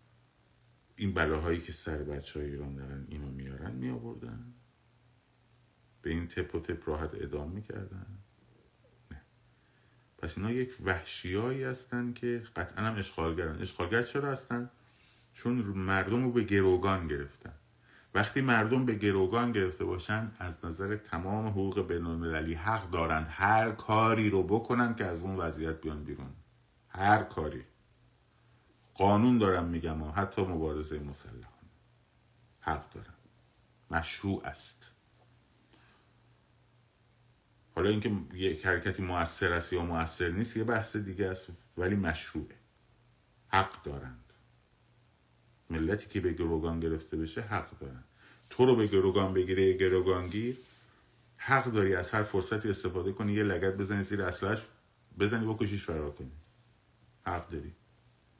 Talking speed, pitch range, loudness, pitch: 130 wpm, 85-115 Hz, -32 LUFS, 100 Hz